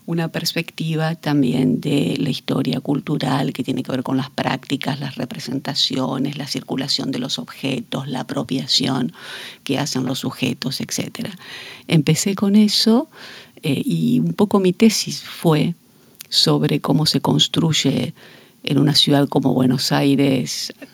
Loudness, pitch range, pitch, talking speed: -19 LUFS, 130-160 Hz, 140 Hz, 140 wpm